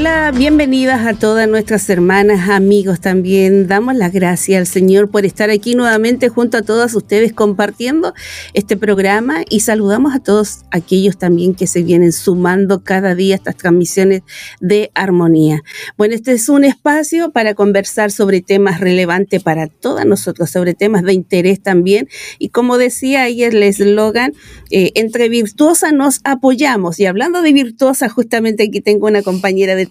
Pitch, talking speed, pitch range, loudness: 205 Hz, 160 wpm, 190-240 Hz, -12 LUFS